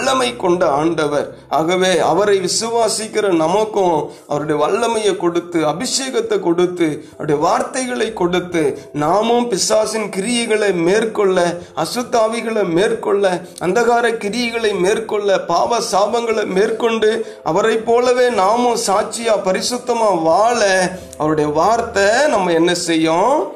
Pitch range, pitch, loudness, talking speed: 175-230 Hz, 205 Hz, -16 LUFS, 95 wpm